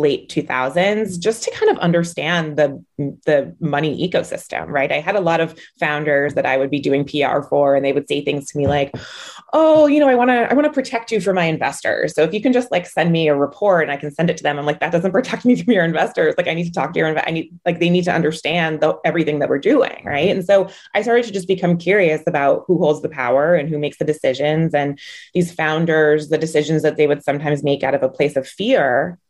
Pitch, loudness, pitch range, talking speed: 160 Hz, -18 LUFS, 145-190 Hz, 260 wpm